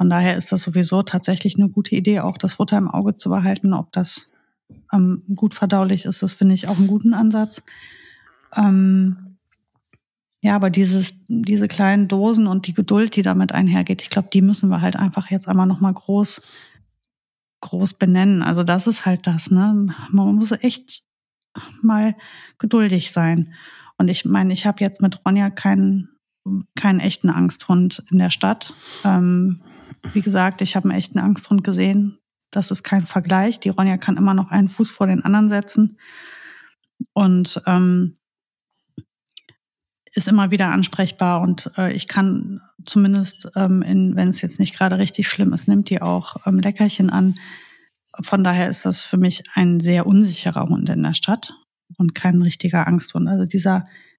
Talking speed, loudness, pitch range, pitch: 170 wpm, -18 LUFS, 185-205 Hz, 195 Hz